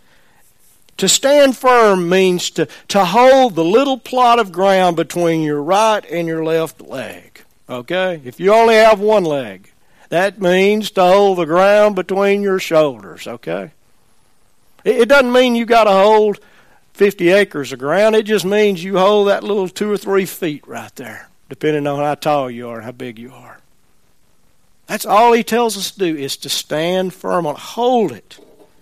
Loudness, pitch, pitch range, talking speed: -14 LUFS, 190 Hz, 155-215 Hz, 180 wpm